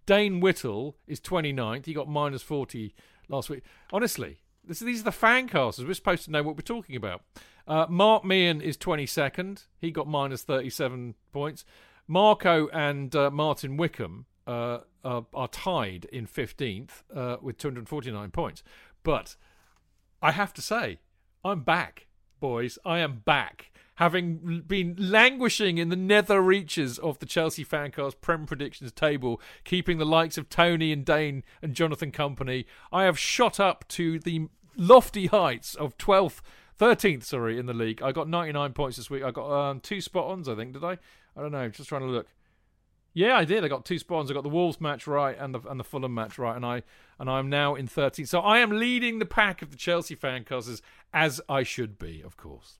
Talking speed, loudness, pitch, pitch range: 195 wpm, -27 LUFS, 150 Hz, 125-175 Hz